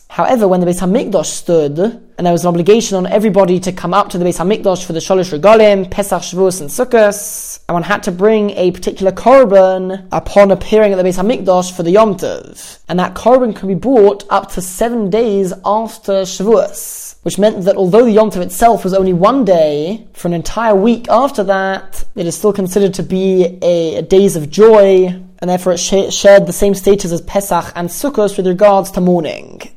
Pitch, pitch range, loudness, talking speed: 195 Hz, 180-210 Hz, -12 LUFS, 205 wpm